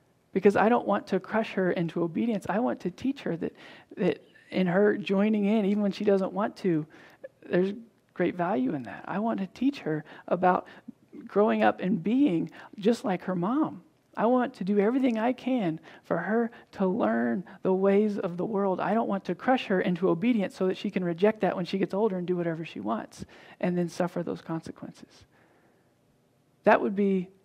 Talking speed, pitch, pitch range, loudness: 200 wpm, 195 Hz, 180-225 Hz, -28 LUFS